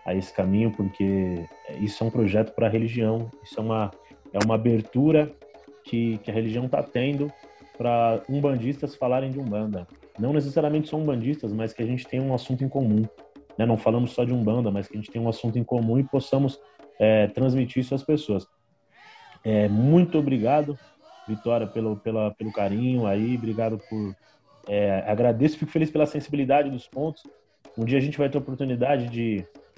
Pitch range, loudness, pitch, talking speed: 110-140 Hz, -25 LUFS, 120 Hz, 185 wpm